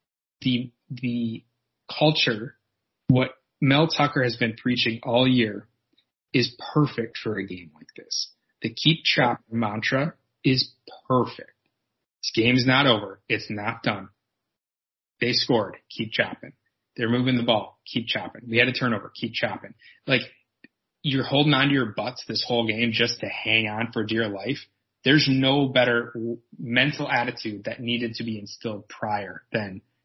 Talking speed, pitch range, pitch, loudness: 155 wpm, 115-130 Hz, 120 Hz, -24 LUFS